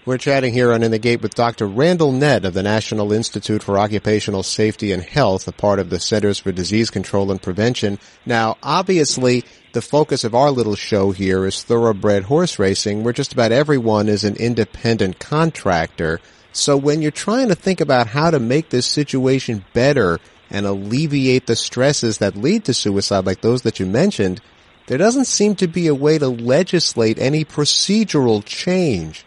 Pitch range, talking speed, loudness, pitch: 105-145 Hz, 180 wpm, -17 LUFS, 115 Hz